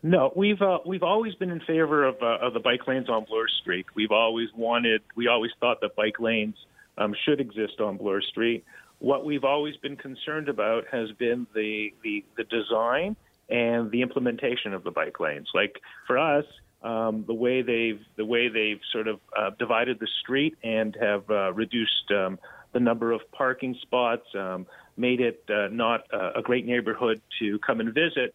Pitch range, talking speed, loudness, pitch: 110-135 Hz, 190 wpm, -26 LUFS, 120 Hz